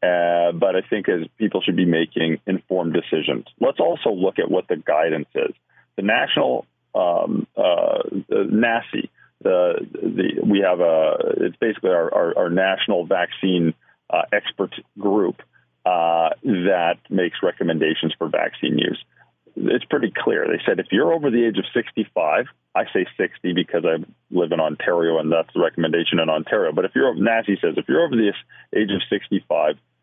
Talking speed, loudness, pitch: 170 wpm, -21 LUFS, 95 Hz